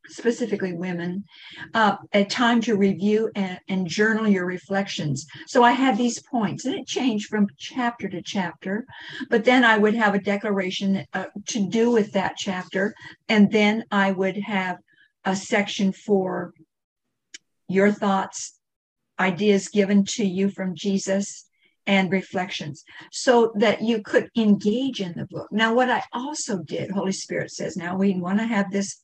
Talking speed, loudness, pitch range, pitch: 160 wpm, -23 LUFS, 190-220 Hz, 200 Hz